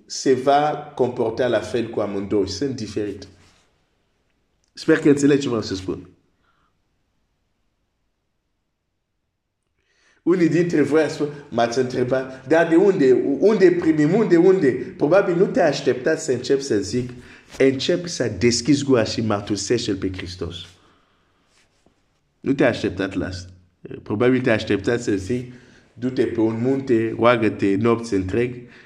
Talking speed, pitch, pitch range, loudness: 135 wpm, 125 Hz, 105-145 Hz, -20 LUFS